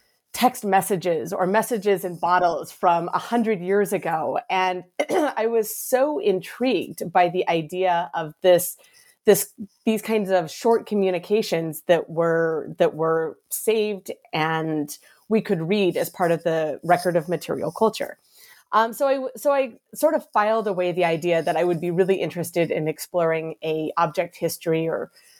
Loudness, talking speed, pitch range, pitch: -23 LUFS, 160 wpm, 170-220 Hz, 185 Hz